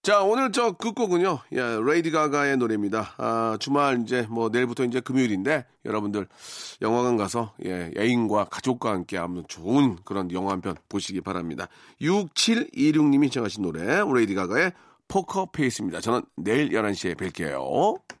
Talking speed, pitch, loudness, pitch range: 335 characters per minute, 120 Hz, -25 LUFS, 100-170 Hz